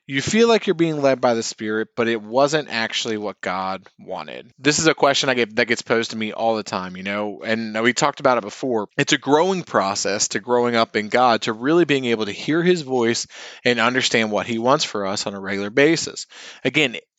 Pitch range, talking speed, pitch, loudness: 110-140 Hz, 235 wpm, 120 Hz, -20 LUFS